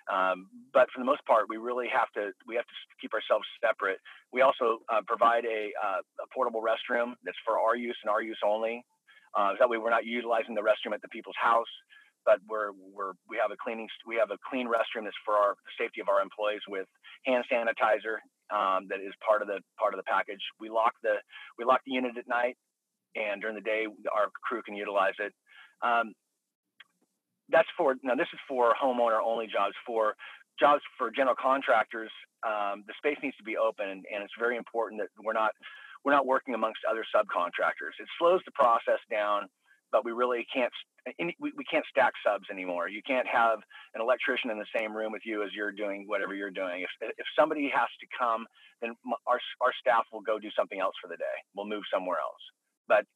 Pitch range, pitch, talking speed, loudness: 105-120 Hz, 115 Hz, 210 wpm, -30 LUFS